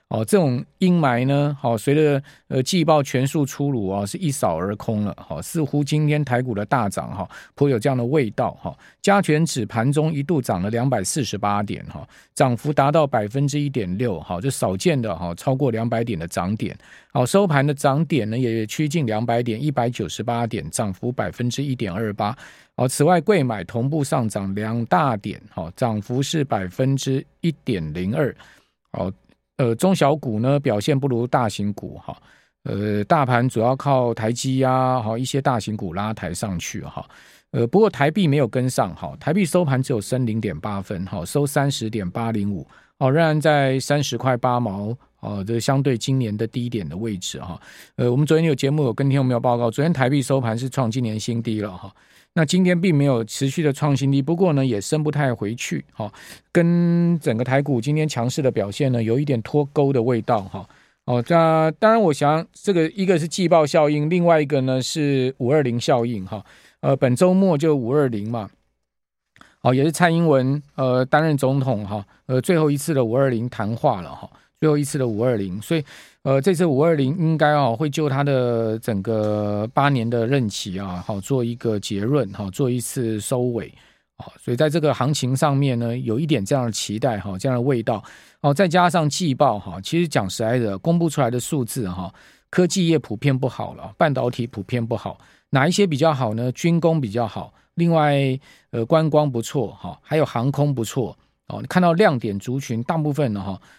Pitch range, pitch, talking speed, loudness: 115-150 Hz, 130 Hz, 295 characters per minute, -21 LUFS